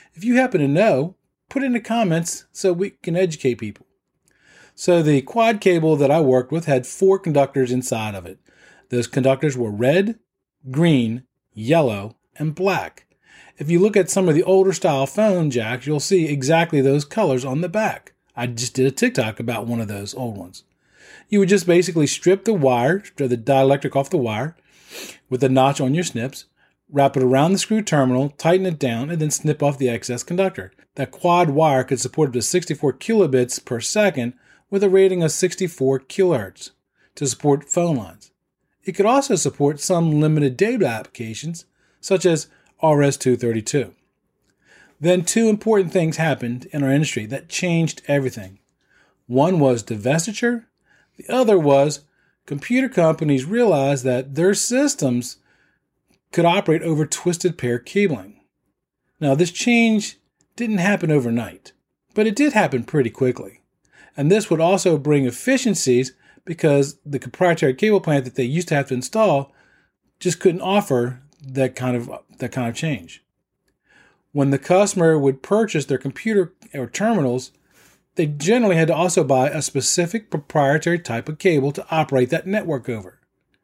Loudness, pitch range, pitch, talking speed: -19 LUFS, 130-185 Hz, 150 Hz, 165 wpm